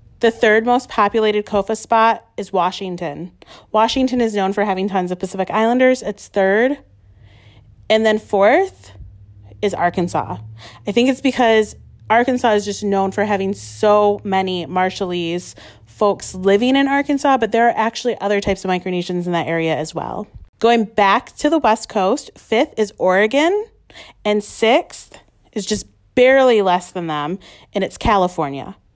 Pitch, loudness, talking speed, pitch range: 205 Hz, -17 LUFS, 155 wpm, 180-230 Hz